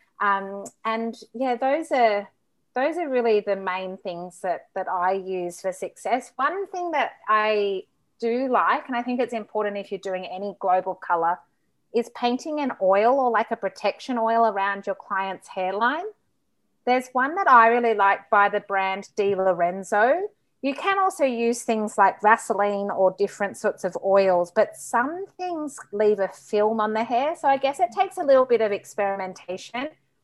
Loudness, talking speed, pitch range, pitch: -23 LUFS, 175 wpm, 195-255 Hz, 215 Hz